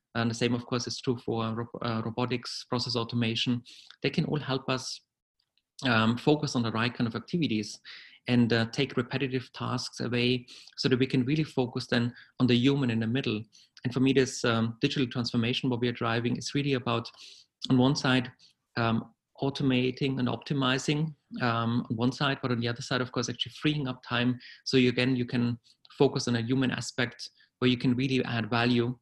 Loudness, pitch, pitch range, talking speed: -29 LUFS, 125 Hz, 120-130 Hz, 200 wpm